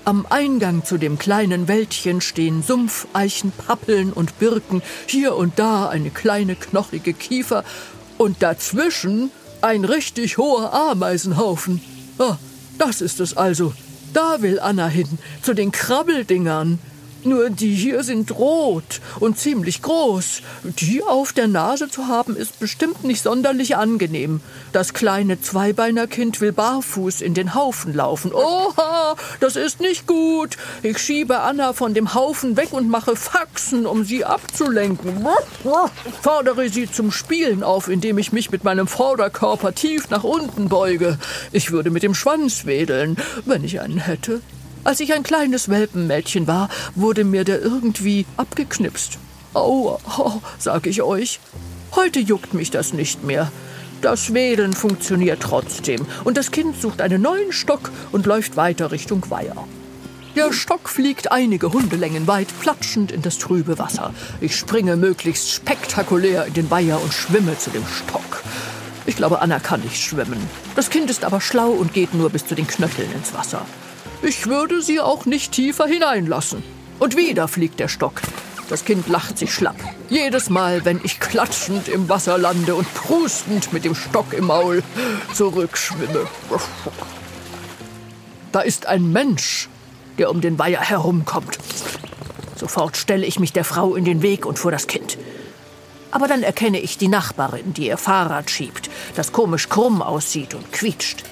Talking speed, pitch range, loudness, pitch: 155 wpm, 175-250 Hz, -19 LUFS, 200 Hz